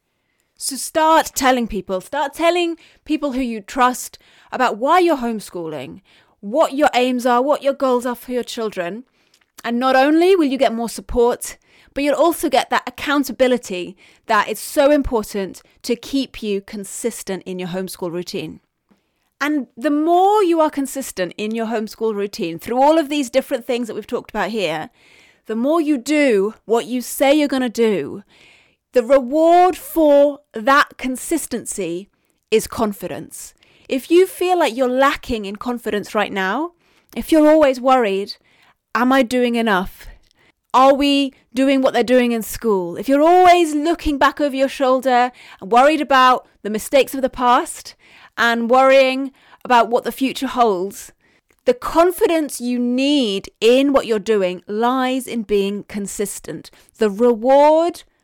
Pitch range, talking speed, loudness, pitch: 225-285 Hz, 155 wpm, -17 LUFS, 255 Hz